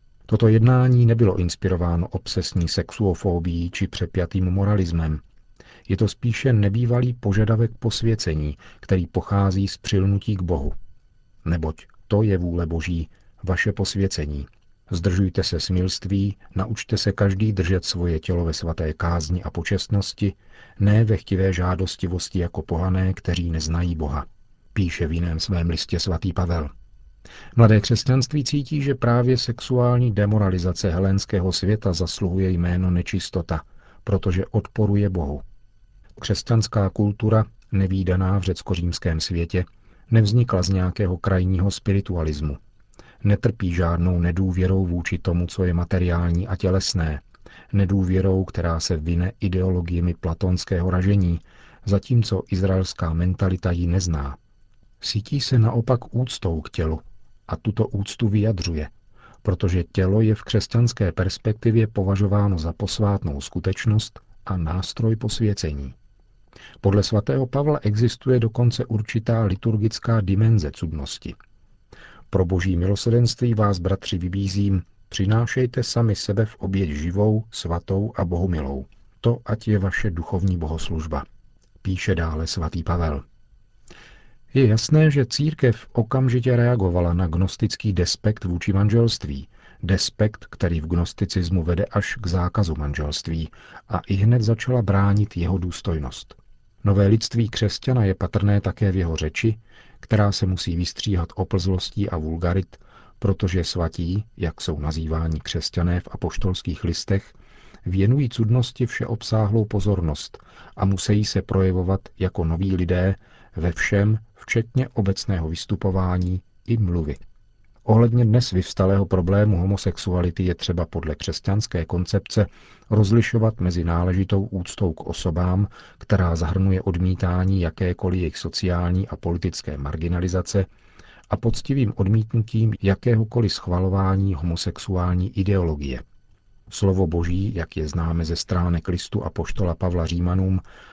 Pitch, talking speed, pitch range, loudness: 95 Hz, 120 wpm, 90-110 Hz, -22 LUFS